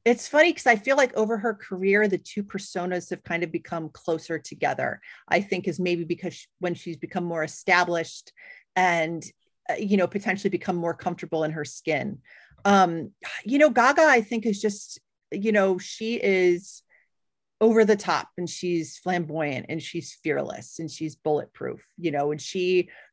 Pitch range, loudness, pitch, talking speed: 170-210 Hz, -25 LUFS, 180 Hz, 170 wpm